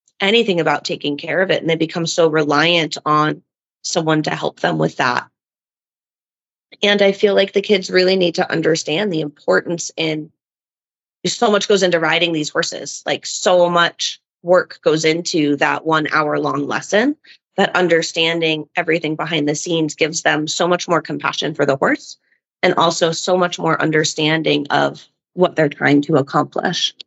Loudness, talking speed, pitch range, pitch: -17 LUFS, 170 wpm, 155-180 Hz, 165 Hz